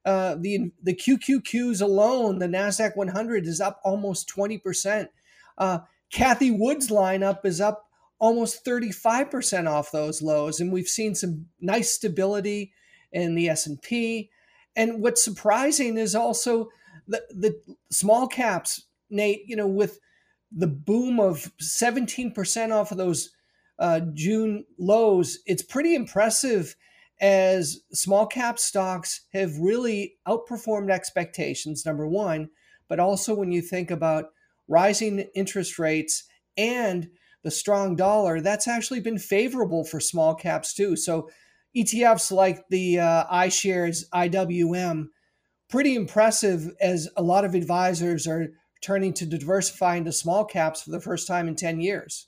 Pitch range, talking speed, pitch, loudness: 175-220 Hz, 135 wpm, 195 Hz, -24 LUFS